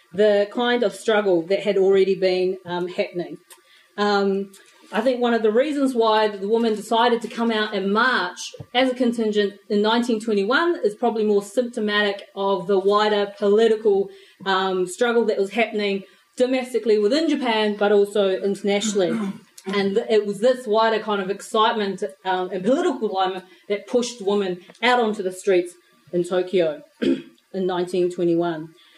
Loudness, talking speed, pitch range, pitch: -21 LUFS, 150 wpm, 195-230 Hz, 205 Hz